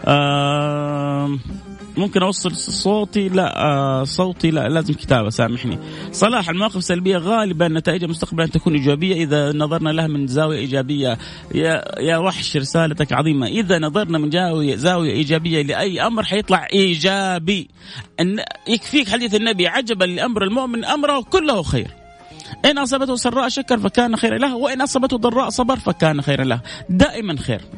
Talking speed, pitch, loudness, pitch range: 145 wpm, 180 Hz, -18 LUFS, 150-215 Hz